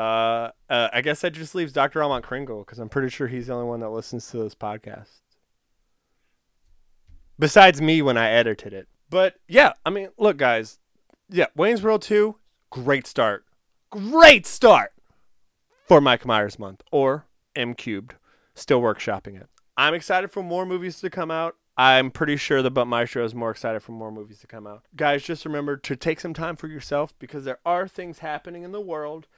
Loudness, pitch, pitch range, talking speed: -21 LUFS, 140 Hz, 115-170 Hz, 190 wpm